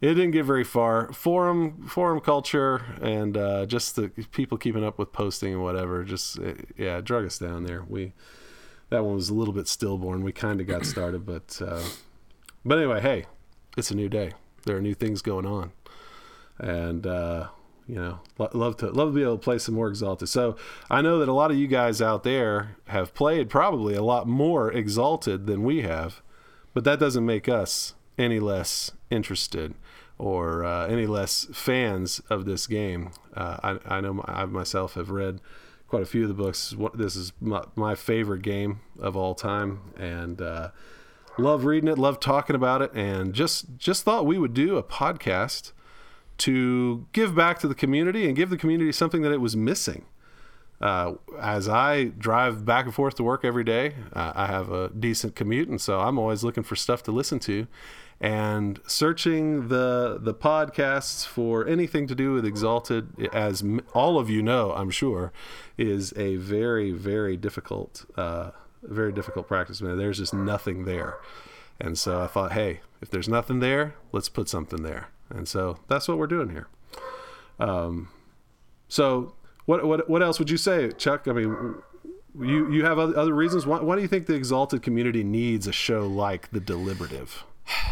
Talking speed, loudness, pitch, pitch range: 185 wpm, -26 LUFS, 110 Hz, 95-135 Hz